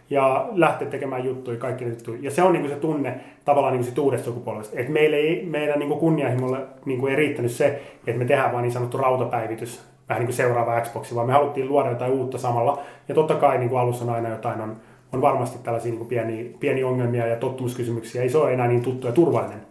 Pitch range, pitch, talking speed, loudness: 120-140 Hz, 125 Hz, 205 wpm, -23 LUFS